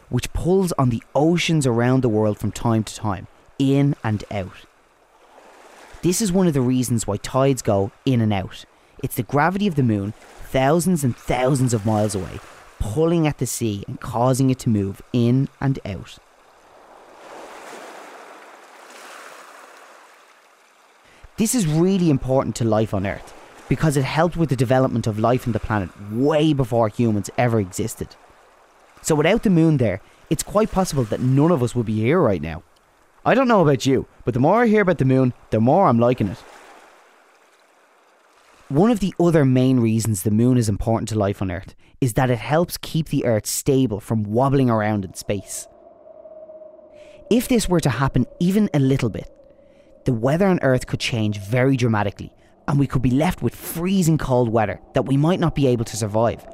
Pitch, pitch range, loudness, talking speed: 130 Hz, 110-160 Hz, -20 LUFS, 180 wpm